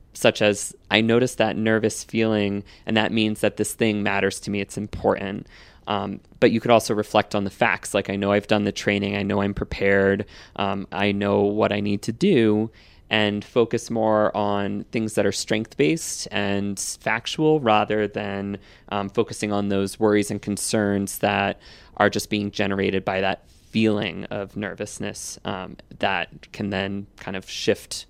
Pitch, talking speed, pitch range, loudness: 105 Hz, 175 wpm, 100-110 Hz, -23 LUFS